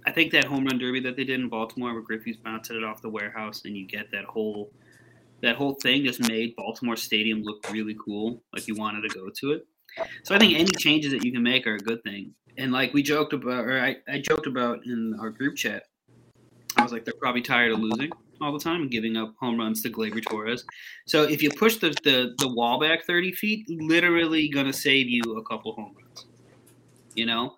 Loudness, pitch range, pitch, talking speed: -25 LUFS, 110-145 Hz, 125 Hz, 235 wpm